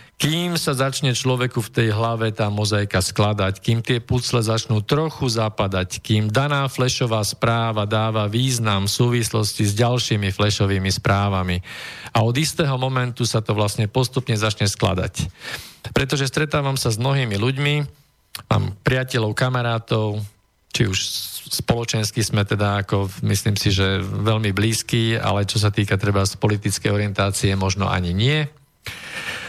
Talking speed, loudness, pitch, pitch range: 140 wpm, -21 LUFS, 110 Hz, 105-125 Hz